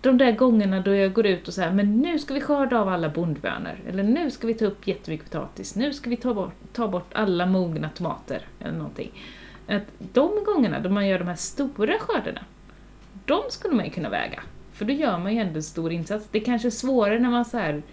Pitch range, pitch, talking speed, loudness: 185-250 Hz, 210 Hz, 240 wpm, -25 LUFS